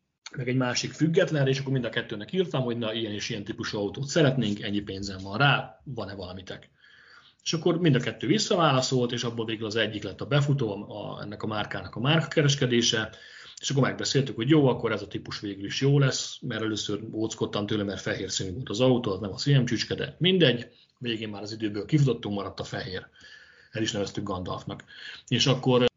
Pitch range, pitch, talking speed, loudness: 105-140 Hz, 120 Hz, 205 wpm, -27 LUFS